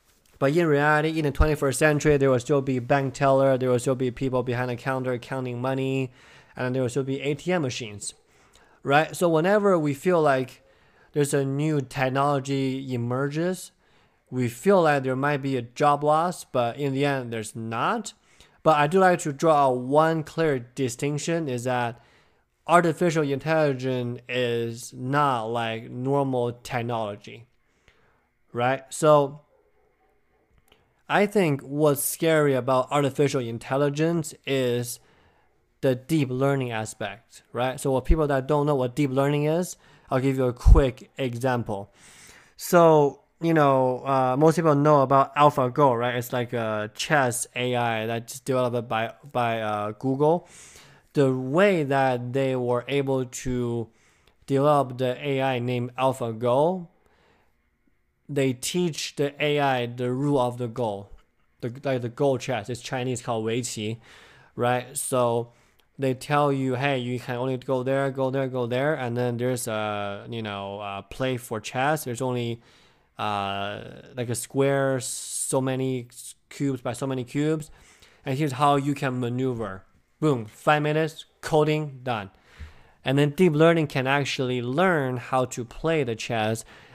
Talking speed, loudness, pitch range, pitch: 150 wpm, -25 LUFS, 120-145 Hz, 130 Hz